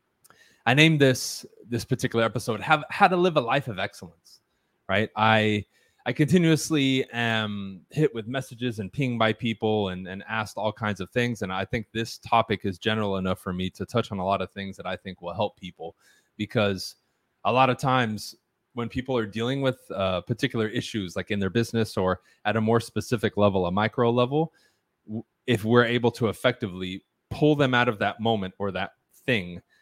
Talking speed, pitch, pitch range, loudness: 190 wpm, 110 Hz, 100-125 Hz, -25 LUFS